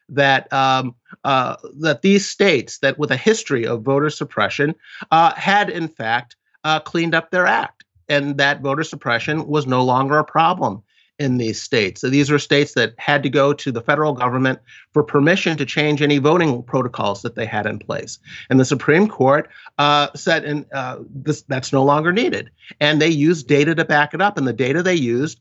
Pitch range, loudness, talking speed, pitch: 135-155 Hz, -18 LUFS, 200 wpm, 145 Hz